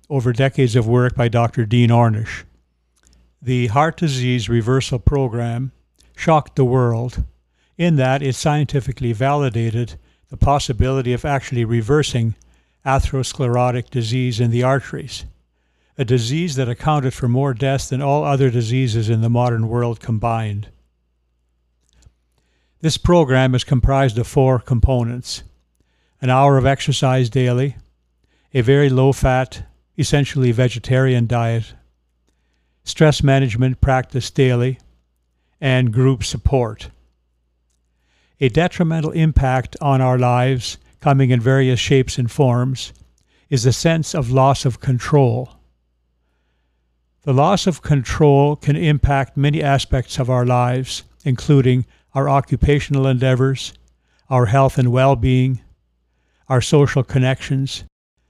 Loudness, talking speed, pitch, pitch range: -17 LUFS, 120 wpm, 125 Hz, 100-135 Hz